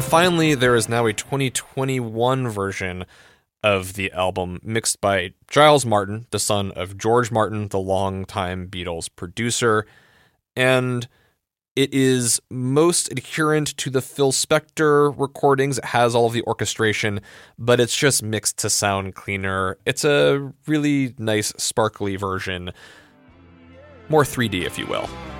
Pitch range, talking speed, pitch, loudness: 95-135 Hz, 135 wpm, 110 Hz, -20 LUFS